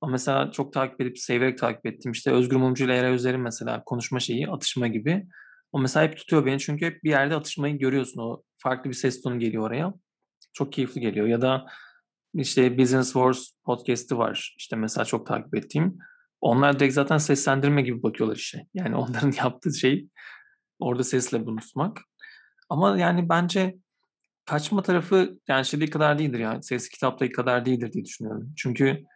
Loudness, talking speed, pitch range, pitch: -25 LUFS, 175 wpm, 125-155 Hz, 135 Hz